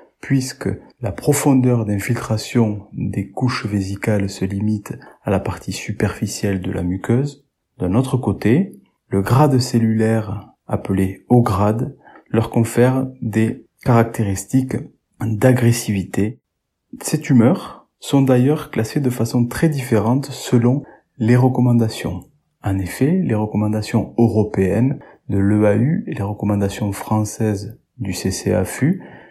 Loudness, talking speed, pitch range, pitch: -19 LUFS, 115 wpm, 105-125 Hz, 110 Hz